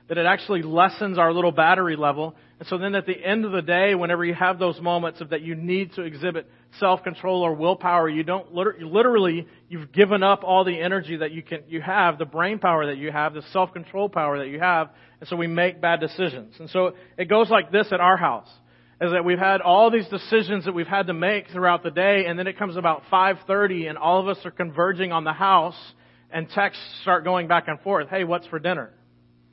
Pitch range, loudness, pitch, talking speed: 165-190 Hz, -22 LUFS, 180 Hz, 240 wpm